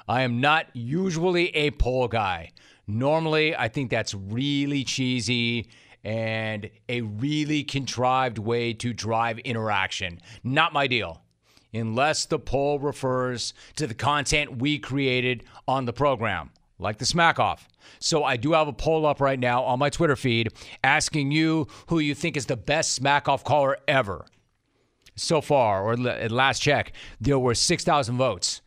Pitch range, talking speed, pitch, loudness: 115-145 Hz, 155 wpm, 130 Hz, -24 LUFS